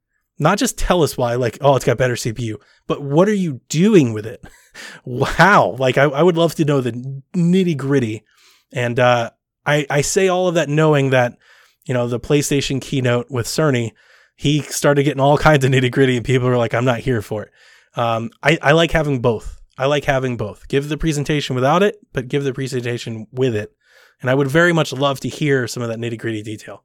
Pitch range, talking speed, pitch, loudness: 120-150 Hz, 220 wpm, 135 Hz, -17 LUFS